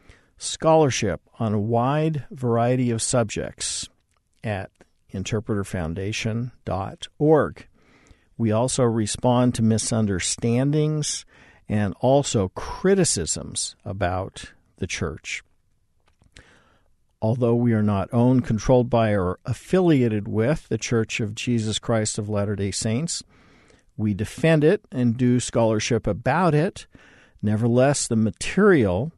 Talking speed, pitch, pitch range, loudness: 105 wpm, 115 Hz, 105-125 Hz, -23 LUFS